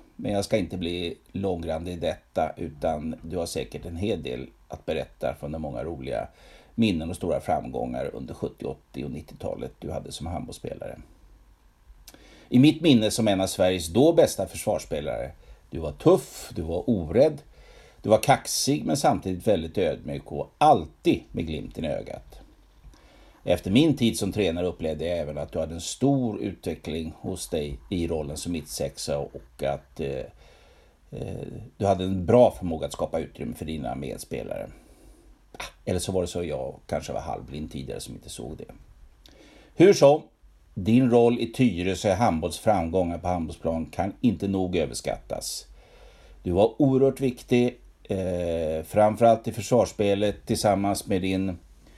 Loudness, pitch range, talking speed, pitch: -26 LUFS, 85-110 Hz, 160 wpm, 95 Hz